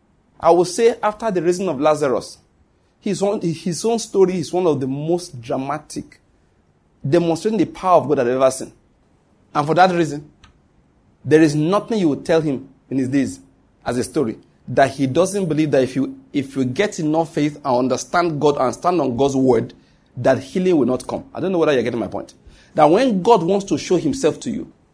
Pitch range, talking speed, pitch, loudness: 135-180 Hz, 205 wpm, 155 Hz, -19 LUFS